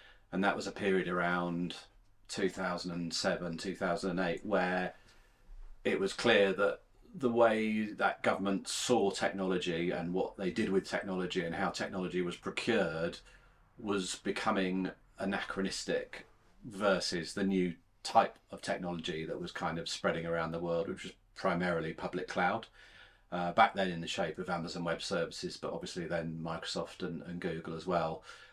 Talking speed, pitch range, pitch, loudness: 150 wpm, 85-100 Hz, 90 Hz, -34 LUFS